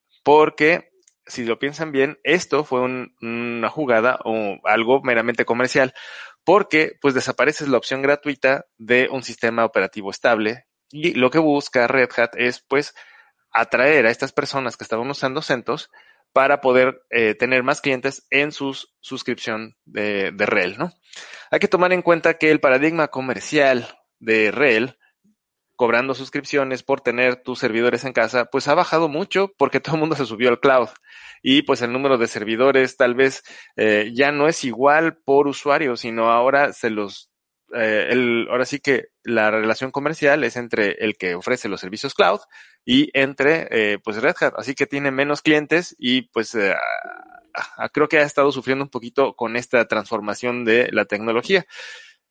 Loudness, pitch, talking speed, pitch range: -19 LUFS, 135 Hz, 170 wpm, 120-150 Hz